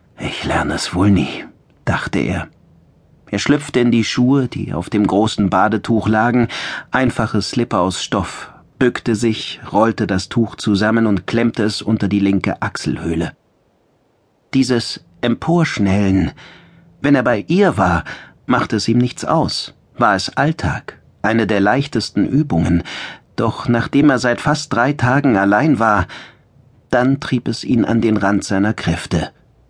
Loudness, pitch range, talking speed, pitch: -17 LUFS, 100-125 Hz, 145 wpm, 115 Hz